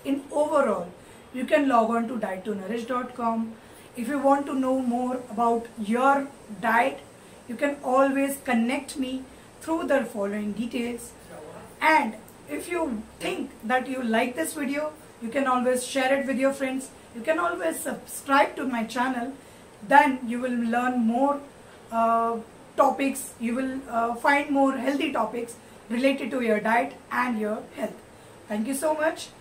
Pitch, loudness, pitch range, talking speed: 255 Hz, -26 LUFS, 235-275 Hz, 155 wpm